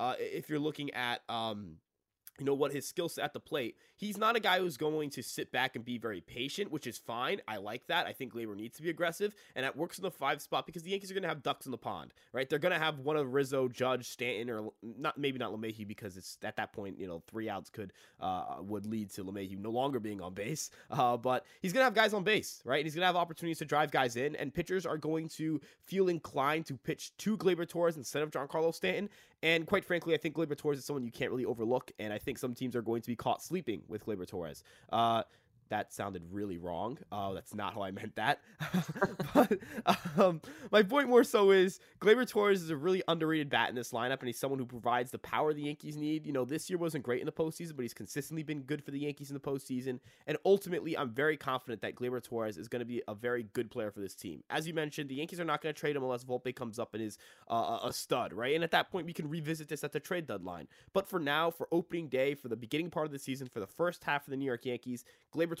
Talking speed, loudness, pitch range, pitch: 270 wpm, -35 LUFS, 120-170 Hz, 145 Hz